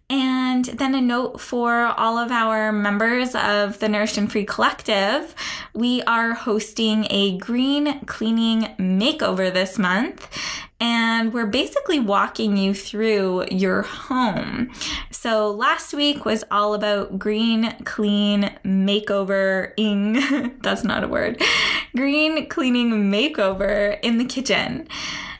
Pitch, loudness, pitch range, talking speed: 225 Hz, -21 LUFS, 205-250 Hz, 125 wpm